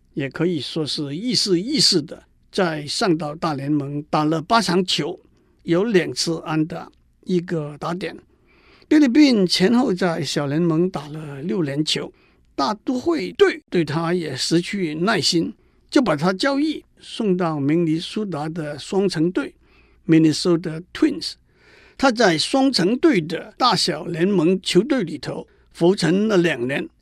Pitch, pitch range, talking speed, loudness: 175 Hz, 160-195 Hz, 225 characters per minute, -20 LUFS